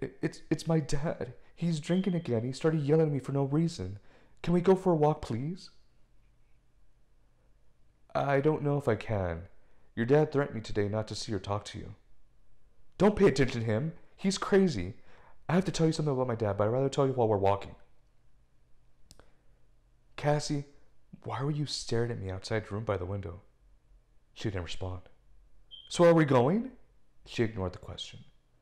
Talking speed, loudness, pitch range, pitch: 185 wpm, -30 LUFS, 105-160 Hz, 130 Hz